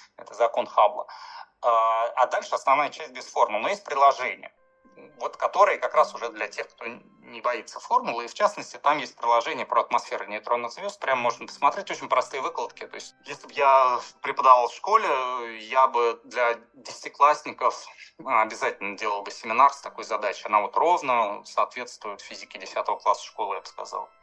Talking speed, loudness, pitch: 170 wpm, -24 LUFS, 135 Hz